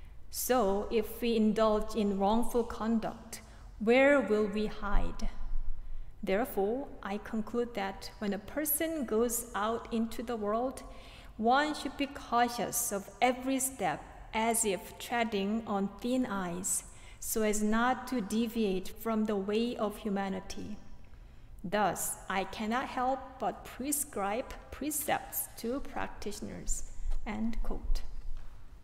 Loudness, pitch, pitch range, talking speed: -33 LUFS, 225 Hz, 205-245 Hz, 120 wpm